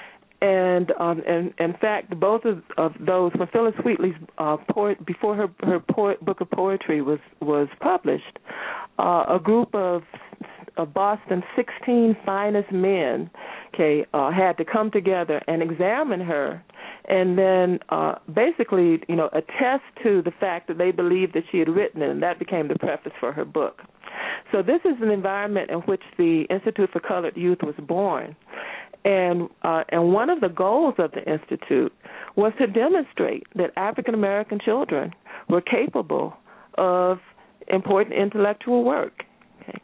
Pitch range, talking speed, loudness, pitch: 175-210 Hz, 160 wpm, -23 LUFS, 190 Hz